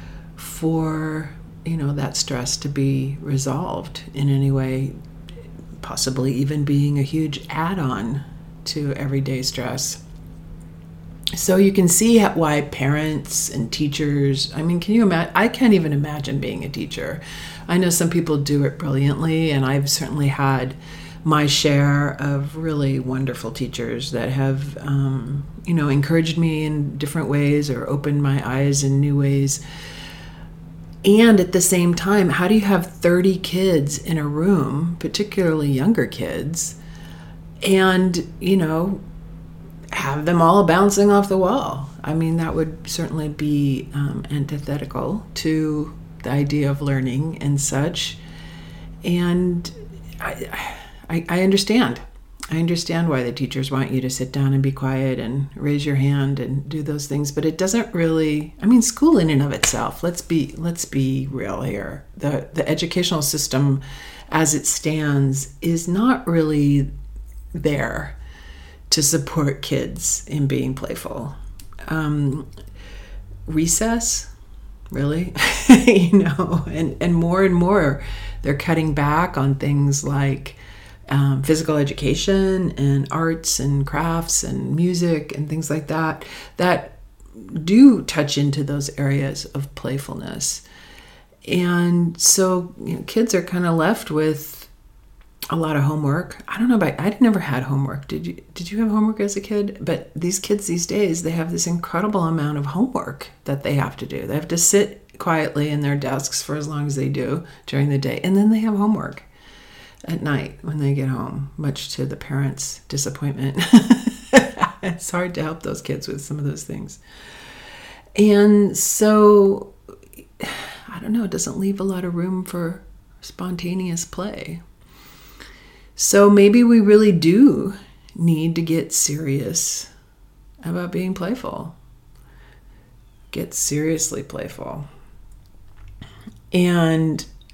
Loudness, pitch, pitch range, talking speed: -20 LUFS, 150 Hz, 135-175 Hz, 145 wpm